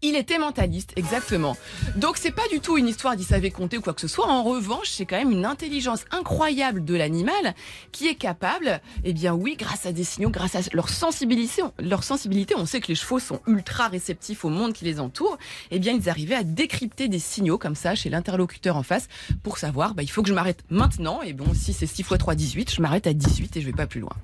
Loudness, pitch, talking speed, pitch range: -25 LUFS, 200 Hz, 250 wpm, 175-255 Hz